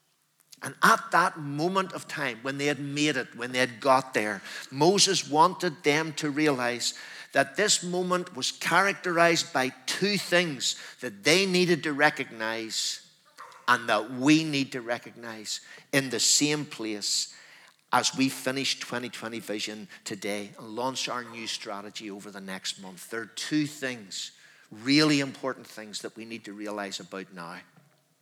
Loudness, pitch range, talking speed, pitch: -27 LUFS, 115-155 Hz, 155 wpm, 135 Hz